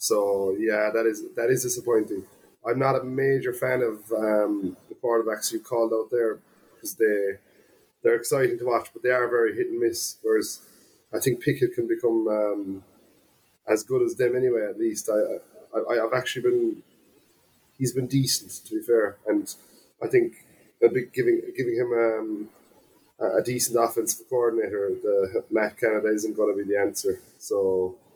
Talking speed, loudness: 170 wpm, -25 LUFS